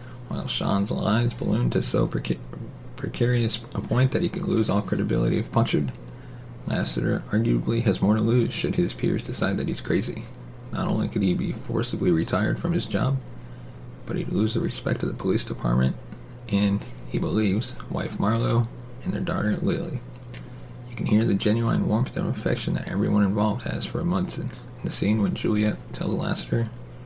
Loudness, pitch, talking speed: -25 LUFS, 105 Hz, 180 wpm